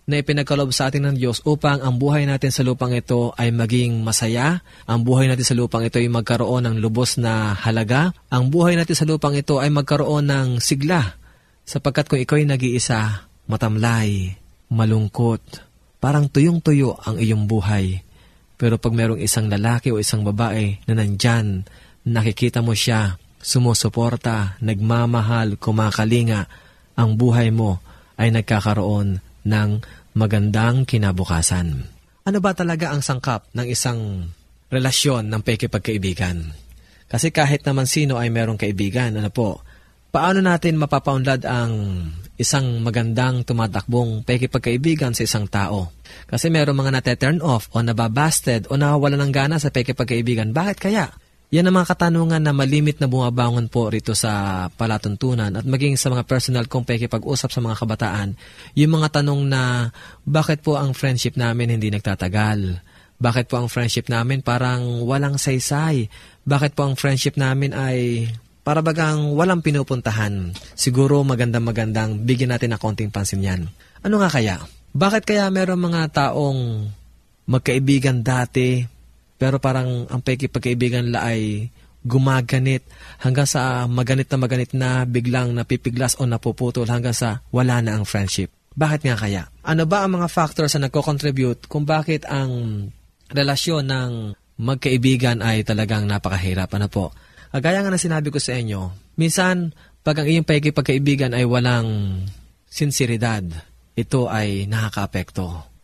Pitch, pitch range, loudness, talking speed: 120 Hz, 110-140 Hz, -20 LUFS, 145 wpm